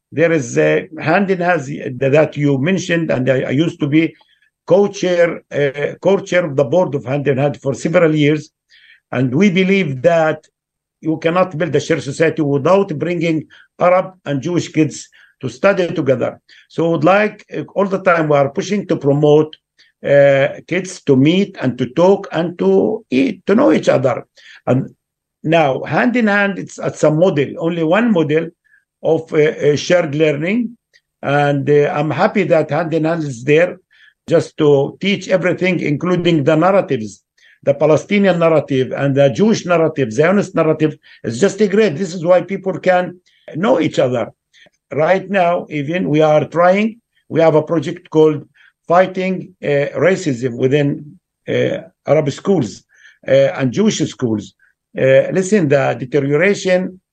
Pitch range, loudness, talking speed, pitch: 145-185 Hz, -15 LUFS, 165 wpm, 160 Hz